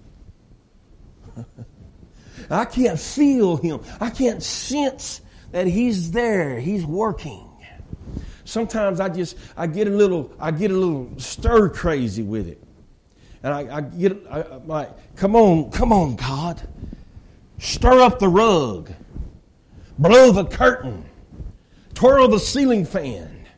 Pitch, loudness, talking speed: 170 Hz, -19 LUFS, 125 wpm